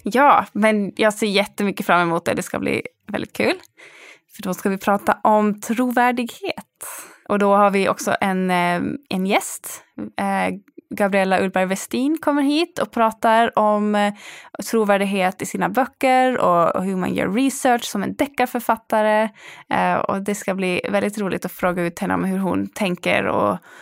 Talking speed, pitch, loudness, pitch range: 160 wpm, 210 Hz, -20 LUFS, 190-245 Hz